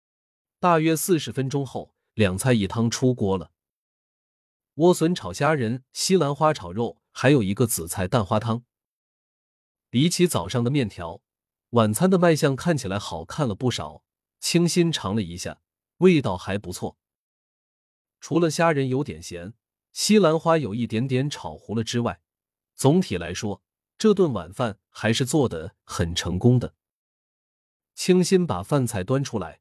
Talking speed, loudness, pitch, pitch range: 215 characters per minute, -23 LUFS, 120 Hz, 95-155 Hz